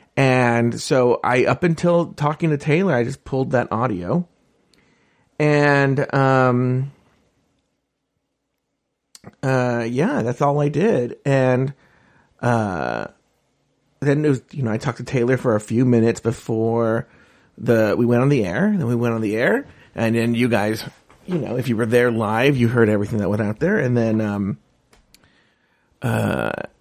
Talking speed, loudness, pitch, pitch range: 160 wpm, -20 LUFS, 125 Hz, 115-140 Hz